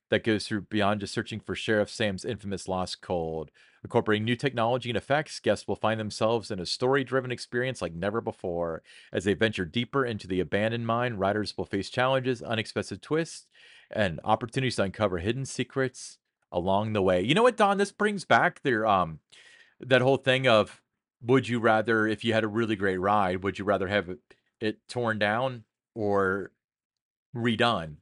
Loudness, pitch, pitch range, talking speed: -27 LUFS, 110 Hz, 100-125 Hz, 180 wpm